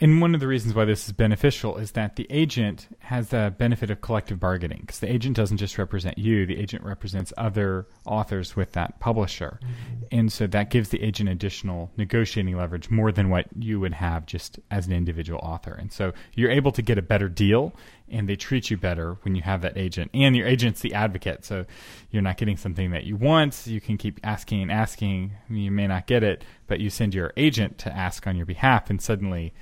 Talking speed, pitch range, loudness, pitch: 220 wpm, 95-115 Hz, -25 LUFS, 105 Hz